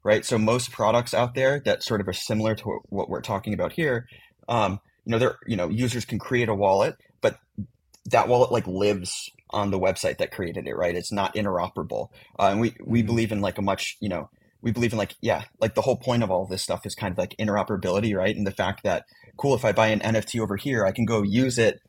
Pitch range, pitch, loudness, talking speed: 100-115 Hz, 110 Hz, -25 LUFS, 250 wpm